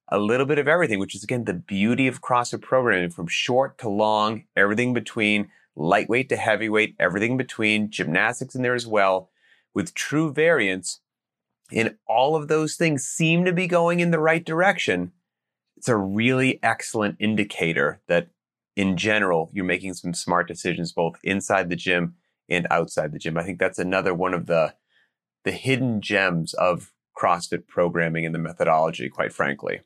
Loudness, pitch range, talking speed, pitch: -23 LUFS, 90-130 Hz, 175 wpm, 105 Hz